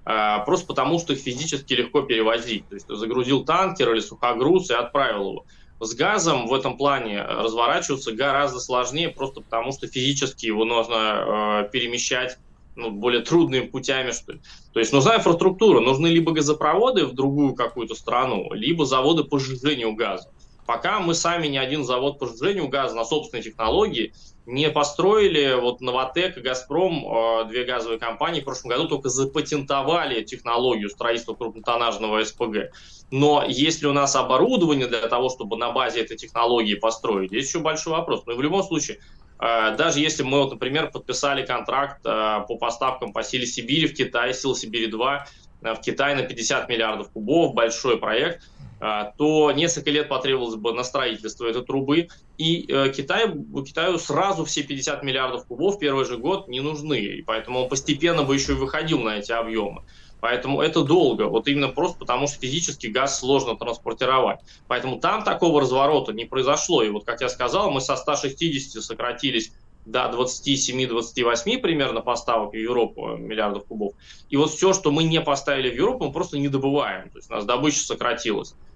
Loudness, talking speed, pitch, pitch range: -22 LUFS, 165 wpm, 135 Hz, 120-150 Hz